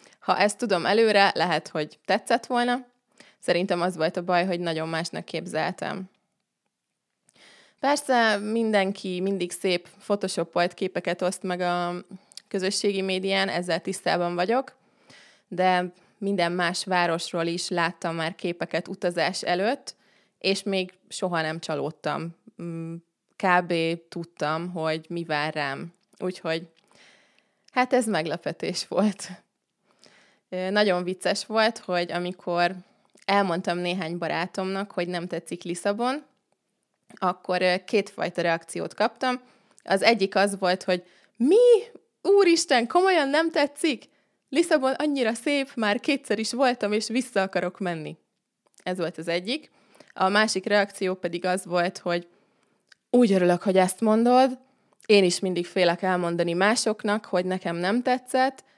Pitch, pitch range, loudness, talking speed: 190 Hz, 175-220 Hz, -25 LUFS, 120 wpm